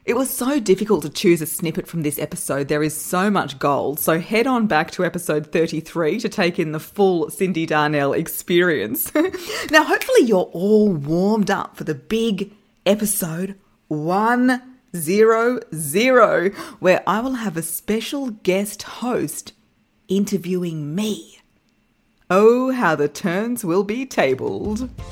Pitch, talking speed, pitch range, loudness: 190 Hz, 145 wpm, 165-225 Hz, -20 LUFS